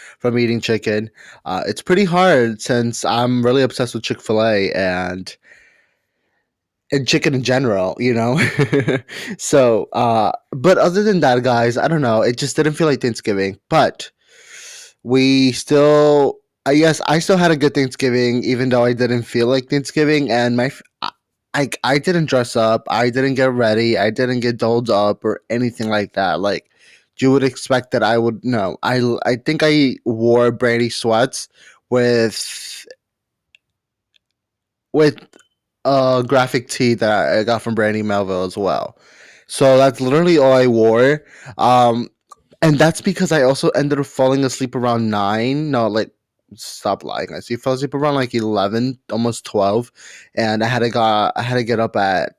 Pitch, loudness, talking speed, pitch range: 125 Hz, -16 LUFS, 165 wpm, 115-135 Hz